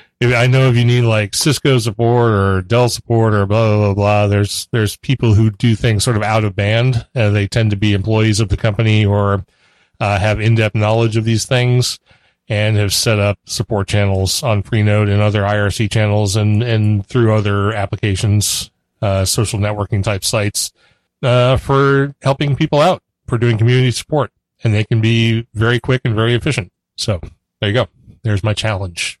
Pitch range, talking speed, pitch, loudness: 105-120 Hz, 185 wpm, 110 Hz, -15 LUFS